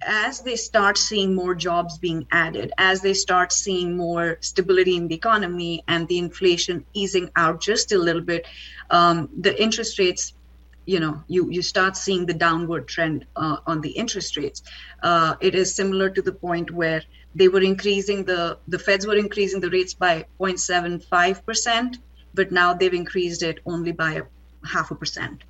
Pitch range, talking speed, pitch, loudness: 170-195 Hz, 175 wpm, 180 Hz, -21 LUFS